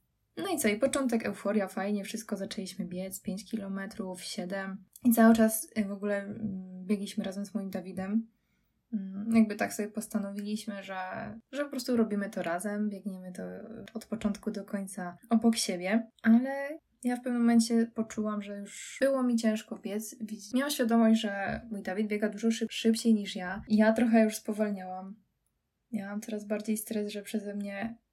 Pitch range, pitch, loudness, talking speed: 200-225 Hz, 215 Hz, -31 LUFS, 160 wpm